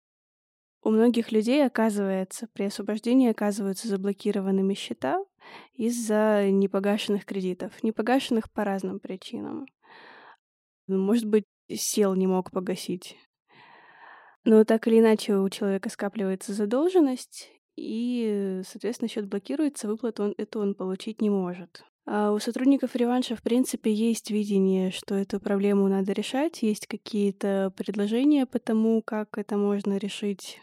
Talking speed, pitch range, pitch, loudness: 125 wpm, 200-235 Hz, 215 Hz, -26 LUFS